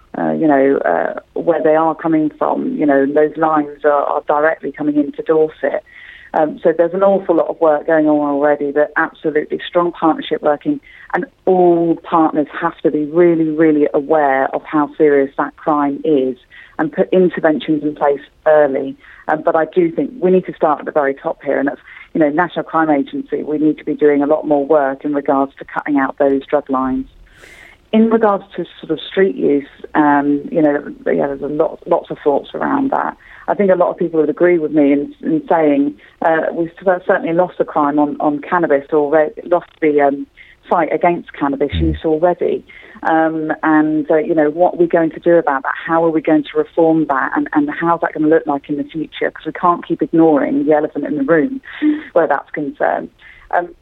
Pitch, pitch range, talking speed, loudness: 155 Hz, 145-170 Hz, 210 wpm, -15 LUFS